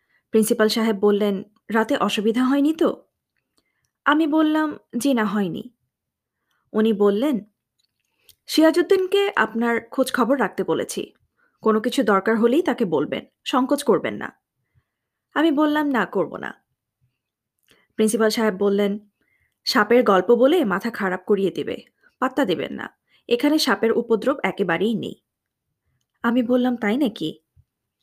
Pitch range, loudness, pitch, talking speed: 205-270 Hz, -21 LUFS, 225 Hz, 120 wpm